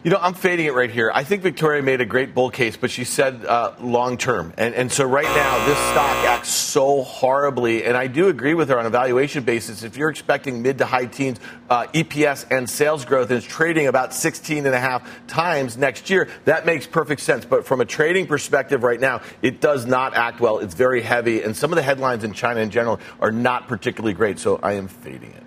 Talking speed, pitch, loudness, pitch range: 240 wpm, 130 Hz, -20 LUFS, 120-145 Hz